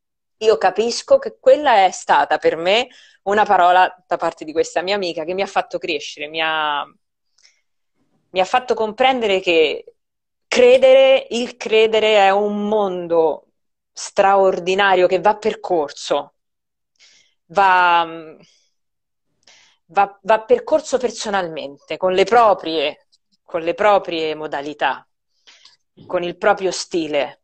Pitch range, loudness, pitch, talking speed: 175-225 Hz, -17 LUFS, 195 Hz, 120 wpm